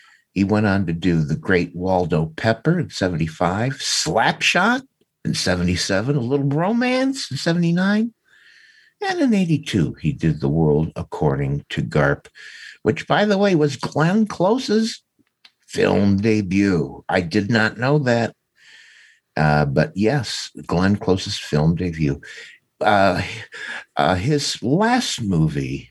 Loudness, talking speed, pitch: -20 LUFS, 125 wpm, 110 Hz